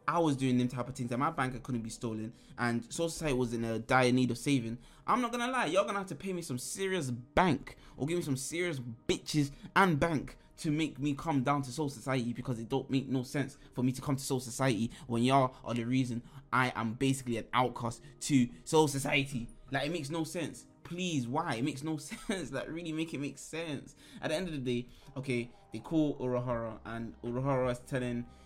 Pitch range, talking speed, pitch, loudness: 125-155 Hz, 230 wpm, 135 Hz, -33 LUFS